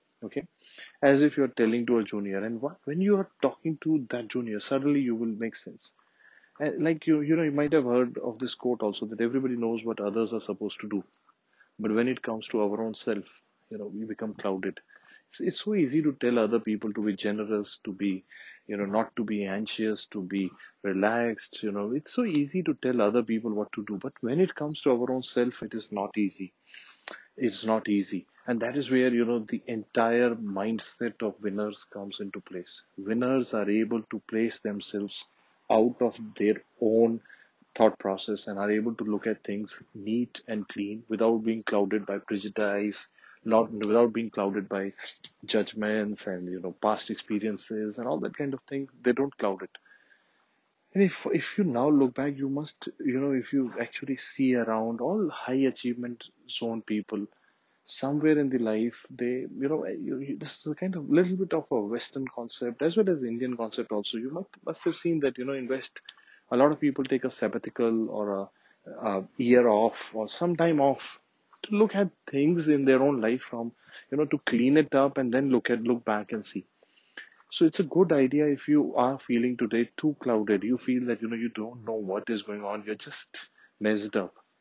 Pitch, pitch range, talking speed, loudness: 115 Hz, 105-135 Hz, 210 wpm, -28 LUFS